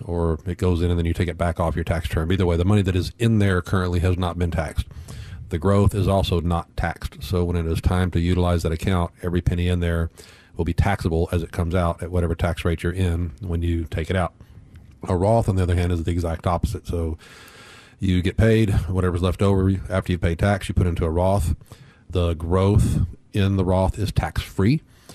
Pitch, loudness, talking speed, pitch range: 90 Hz, -22 LUFS, 235 wpm, 85-95 Hz